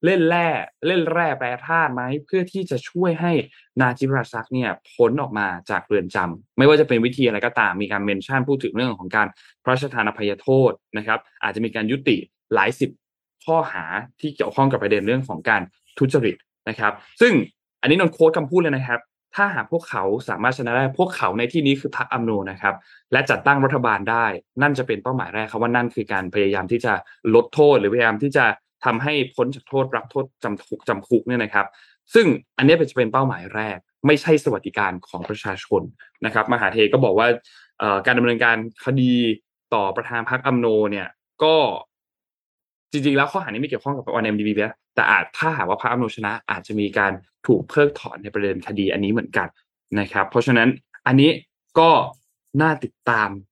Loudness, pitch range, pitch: -20 LUFS, 110-145 Hz, 125 Hz